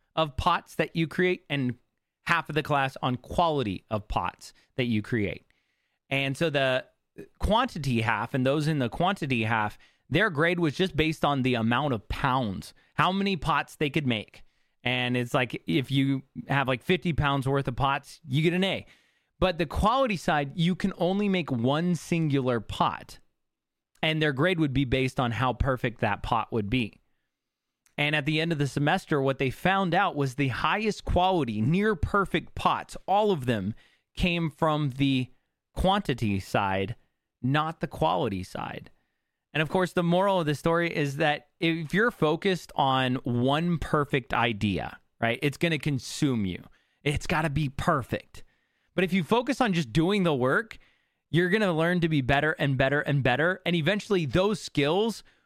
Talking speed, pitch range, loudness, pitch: 175 wpm, 130-175 Hz, -27 LUFS, 145 Hz